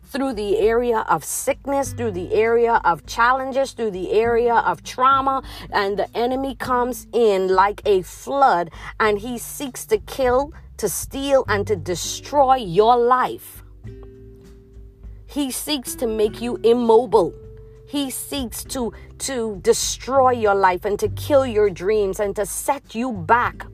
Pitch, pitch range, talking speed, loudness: 240 Hz, 205-270 Hz, 145 wpm, -20 LUFS